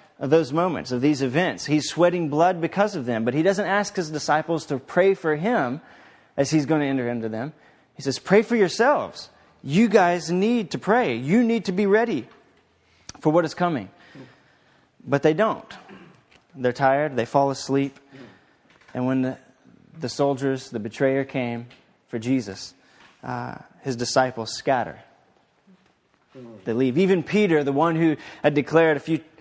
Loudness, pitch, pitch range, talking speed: -23 LUFS, 150 Hz, 130-180 Hz, 165 wpm